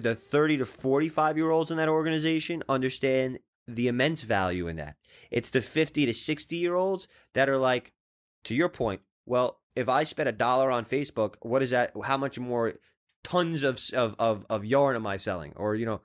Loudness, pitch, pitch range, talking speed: -28 LUFS, 130 Hz, 115-155 Hz, 200 wpm